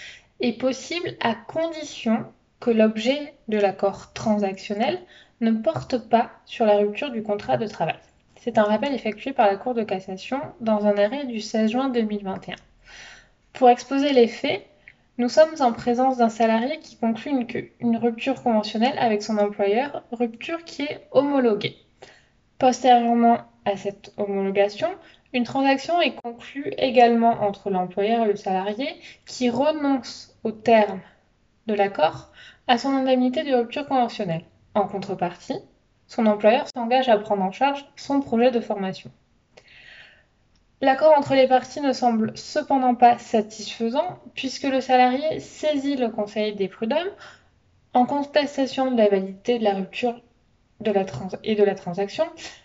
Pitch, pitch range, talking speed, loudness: 240 Hz, 210-270 Hz, 150 wpm, -23 LUFS